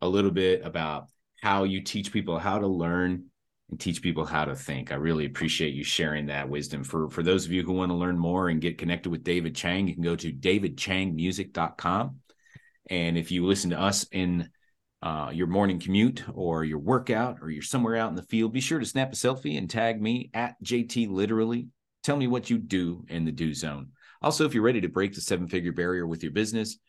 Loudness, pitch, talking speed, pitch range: -28 LUFS, 90 Hz, 225 wpm, 85-110 Hz